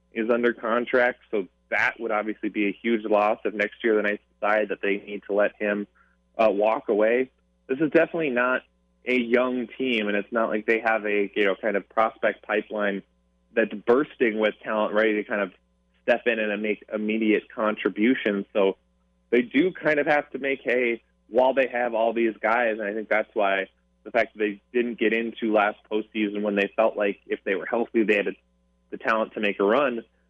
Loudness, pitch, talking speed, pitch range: -24 LUFS, 105 Hz, 210 wpm, 100-115 Hz